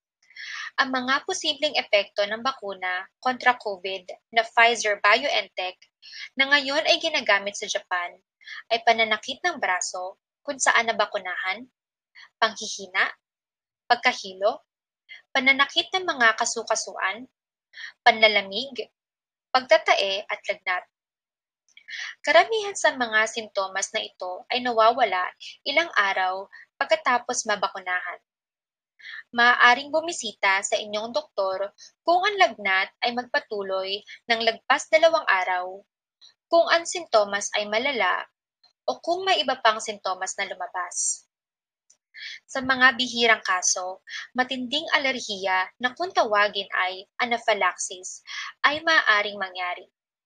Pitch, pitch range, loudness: 230 Hz, 200-290 Hz, -23 LUFS